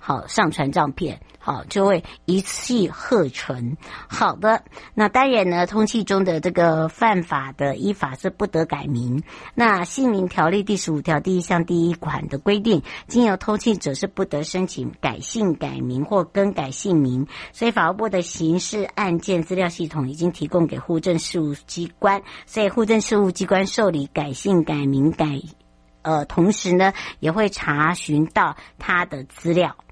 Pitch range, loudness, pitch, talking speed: 155-200 Hz, -21 LUFS, 175 Hz, 250 characters per minute